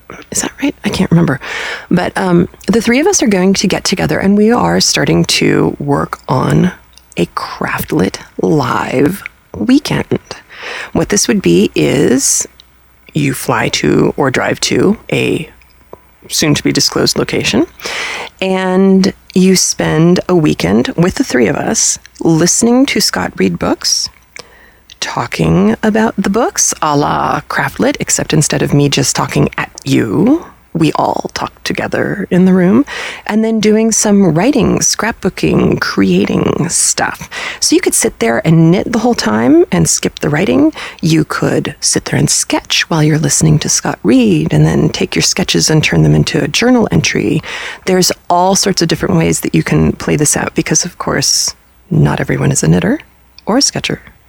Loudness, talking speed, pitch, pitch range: -12 LUFS, 165 wpm, 190 Hz, 165-225 Hz